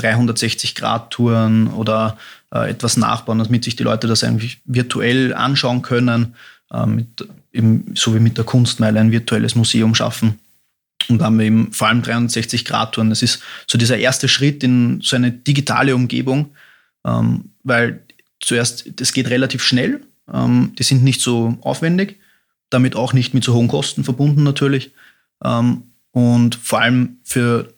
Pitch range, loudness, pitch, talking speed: 115-130 Hz, -16 LUFS, 120 Hz, 160 wpm